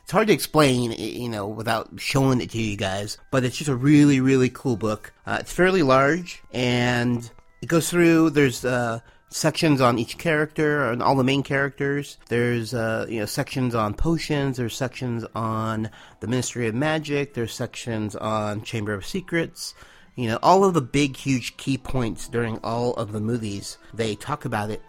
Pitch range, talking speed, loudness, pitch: 110-140 Hz, 185 wpm, -23 LUFS, 125 Hz